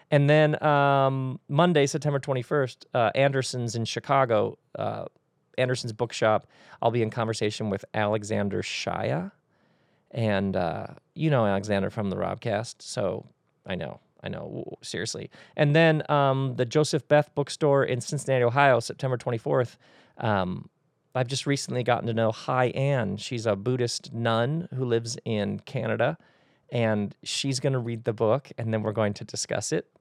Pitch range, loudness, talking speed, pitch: 115-140 Hz, -26 LUFS, 155 wpm, 125 Hz